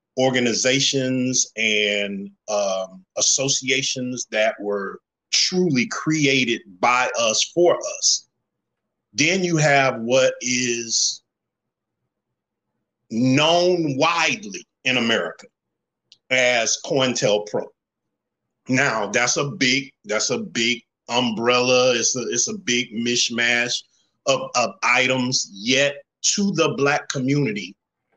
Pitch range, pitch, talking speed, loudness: 115-140 Hz, 130 Hz, 100 wpm, -20 LUFS